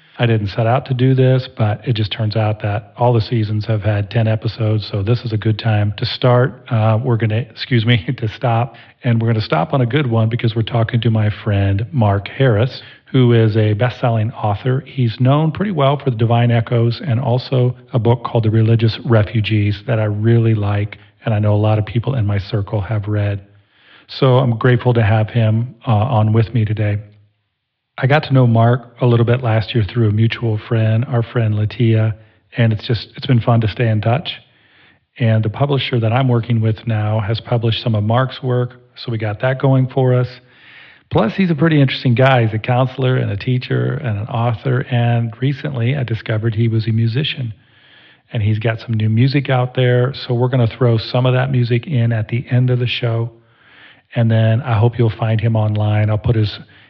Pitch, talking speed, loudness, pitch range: 115 Hz, 220 wpm, -16 LUFS, 110-125 Hz